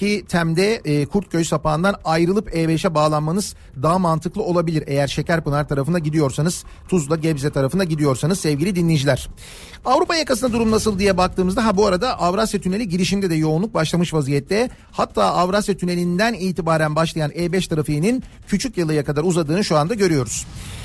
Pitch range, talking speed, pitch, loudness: 155-200 Hz, 140 wpm, 175 Hz, -19 LUFS